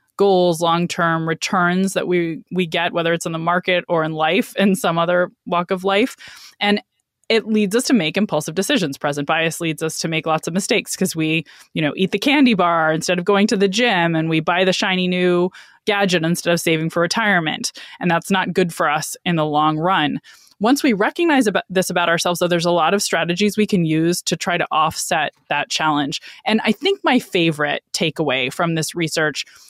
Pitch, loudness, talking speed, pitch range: 175 Hz, -18 LUFS, 215 wpm, 165-200 Hz